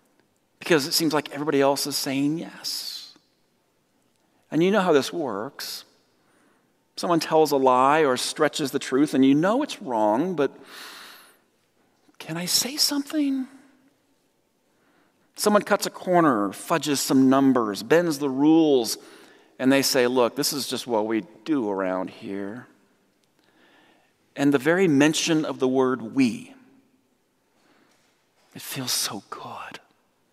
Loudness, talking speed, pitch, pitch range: -23 LUFS, 135 wpm, 150 Hz, 135-205 Hz